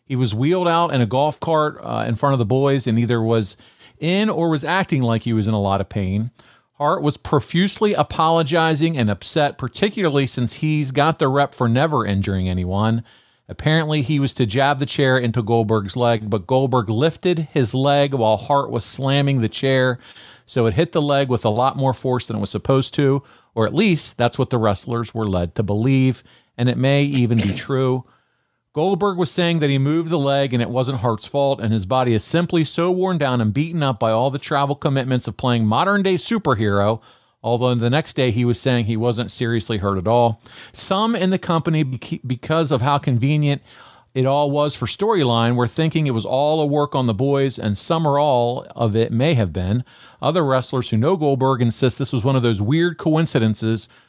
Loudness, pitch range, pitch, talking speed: -19 LUFS, 115-150 Hz, 130 Hz, 210 wpm